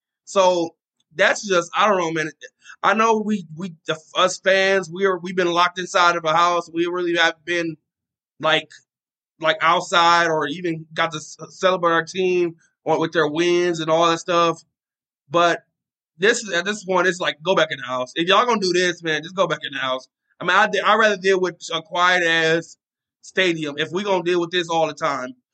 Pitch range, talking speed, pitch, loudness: 160-185 Hz, 205 wpm, 170 Hz, -20 LUFS